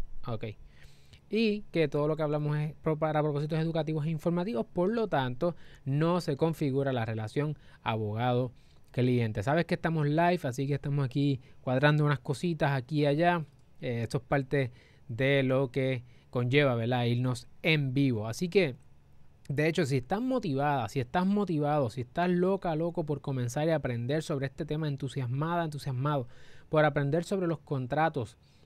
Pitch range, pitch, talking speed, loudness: 130-160 Hz, 145 Hz, 160 wpm, -30 LUFS